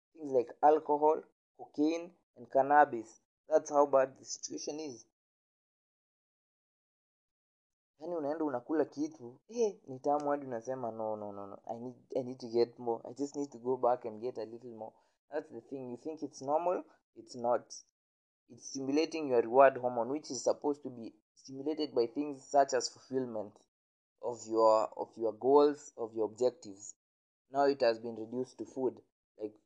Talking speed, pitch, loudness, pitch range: 160 wpm, 130 Hz, -33 LUFS, 115-145 Hz